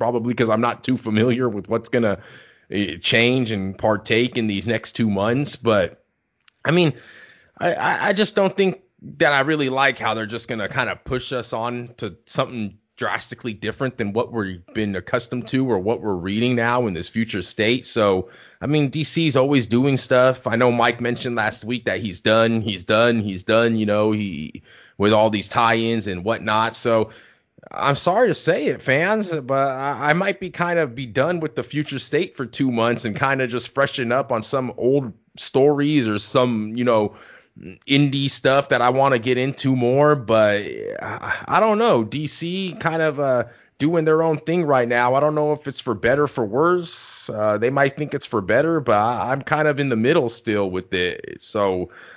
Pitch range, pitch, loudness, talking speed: 110-140 Hz, 125 Hz, -20 LUFS, 200 wpm